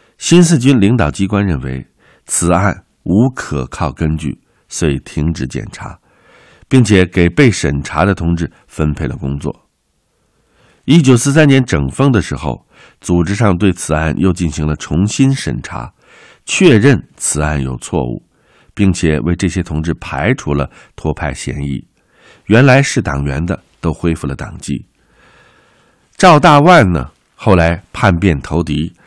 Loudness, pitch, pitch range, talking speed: -13 LUFS, 85 Hz, 75-100 Hz, 210 characters per minute